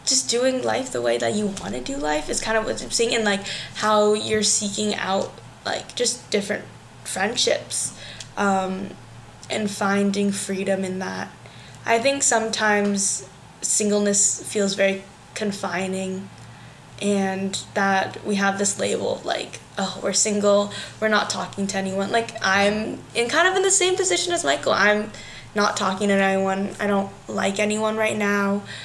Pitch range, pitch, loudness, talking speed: 195-215 Hz, 200 Hz, -22 LUFS, 160 wpm